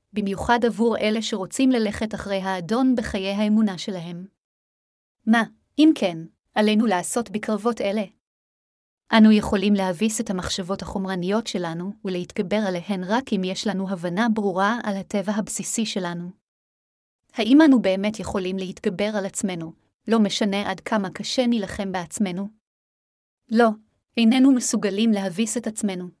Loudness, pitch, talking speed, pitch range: -22 LUFS, 210 Hz, 130 wpm, 190-225 Hz